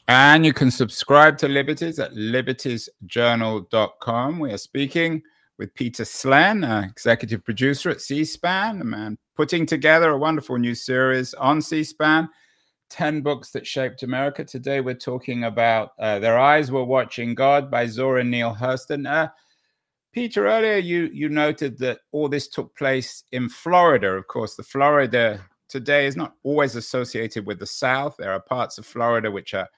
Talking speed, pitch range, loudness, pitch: 165 wpm, 120-150 Hz, -21 LUFS, 135 Hz